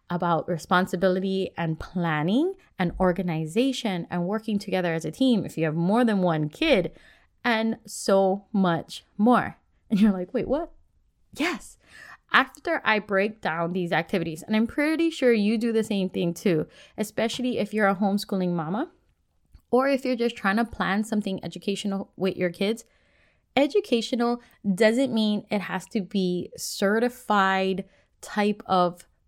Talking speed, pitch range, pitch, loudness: 150 wpm, 180-235 Hz, 200 Hz, -25 LUFS